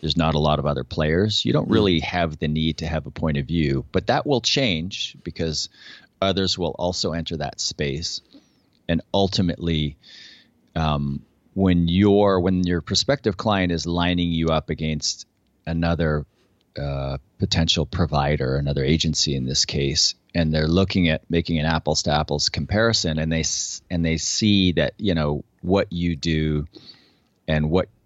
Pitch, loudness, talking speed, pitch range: 80 Hz, -22 LUFS, 165 wpm, 75-90 Hz